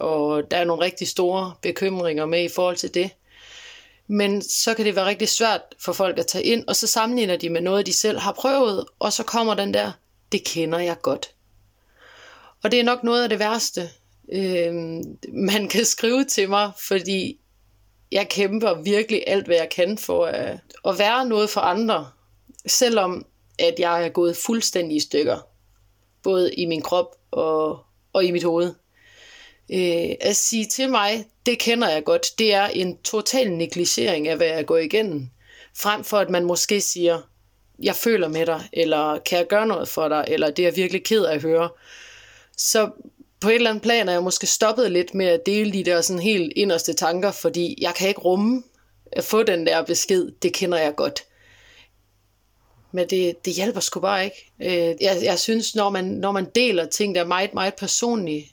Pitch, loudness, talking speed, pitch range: 185 Hz, -21 LUFS, 190 wpm, 165-215 Hz